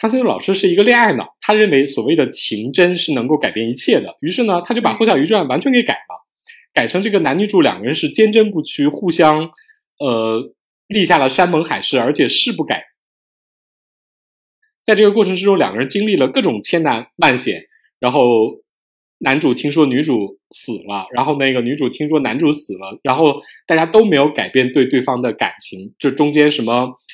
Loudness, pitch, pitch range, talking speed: -15 LUFS, 165 Hz, 140-220 Hz, 295 characters per minute